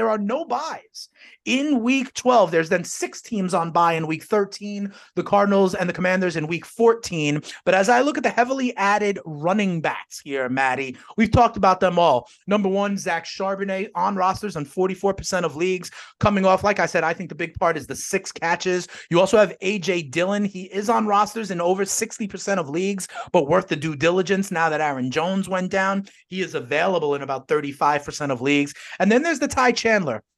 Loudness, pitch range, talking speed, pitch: -22 LUFS, 165-205 Hz, 205 wpm, 190 Hz